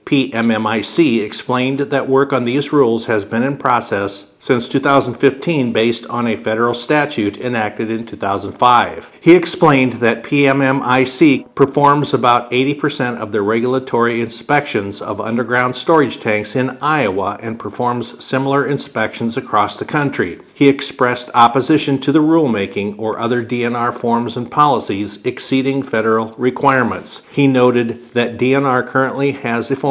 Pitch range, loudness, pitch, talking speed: 115-135 Hz, -15 LUFS, 125 Hz, 135 wpm